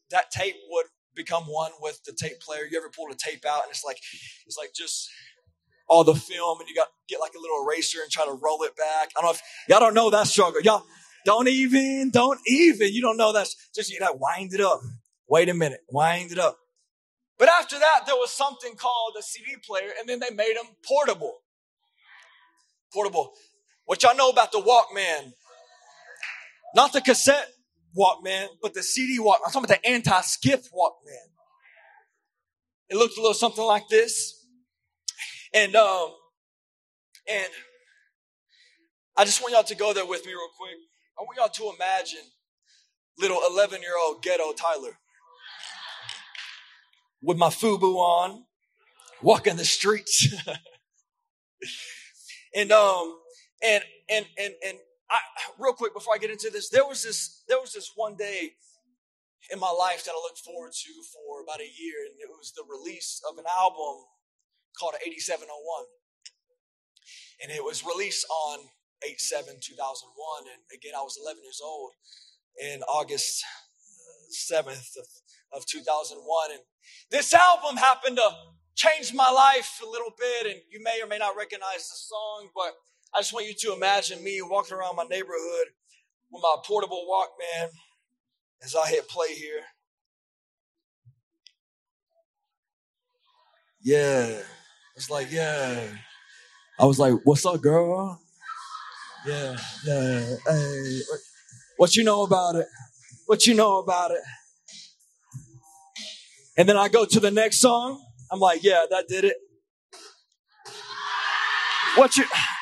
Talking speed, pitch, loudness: 155 wpm, 215 Hz, -23 LUFS